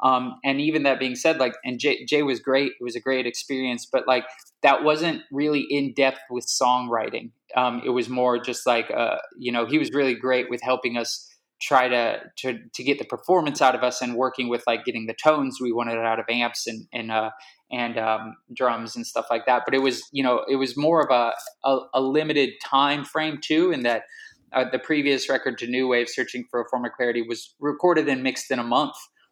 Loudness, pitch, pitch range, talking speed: -24 LUFS, 130 Hz, 120-140 Hz, 225 wpm